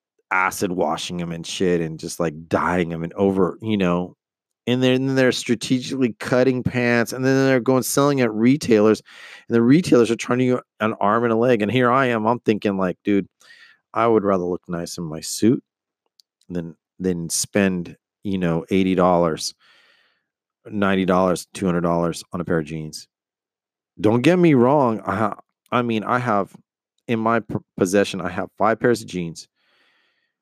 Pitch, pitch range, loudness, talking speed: 105 Hz, 90-125 Hz, -20 LUFS, 185 wpm